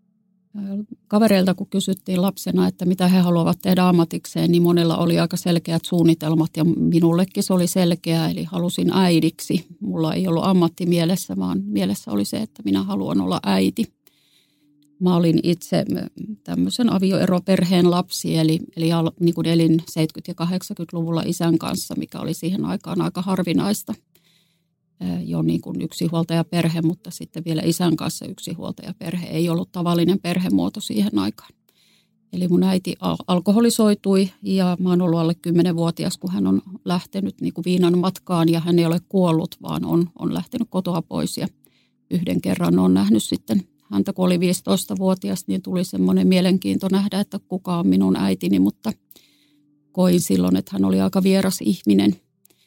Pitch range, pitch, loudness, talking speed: 160-185 Hz, 175 Hz, -20 LUFS, 155 wpm